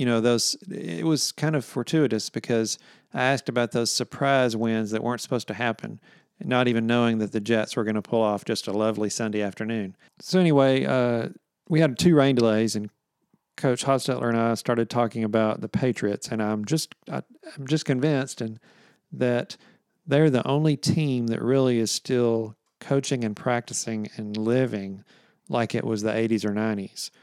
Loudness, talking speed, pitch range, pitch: -25 LUFS, 185 wpm, 110-135 Hz, 120 Hz